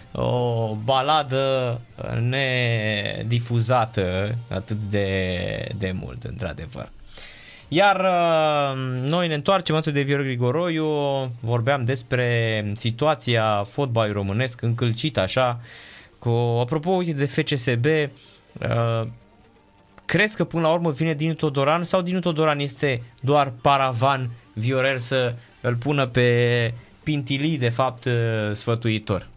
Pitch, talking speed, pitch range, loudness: 125 Hz, 105 wpm, 115-145 Hz, -23 LUFS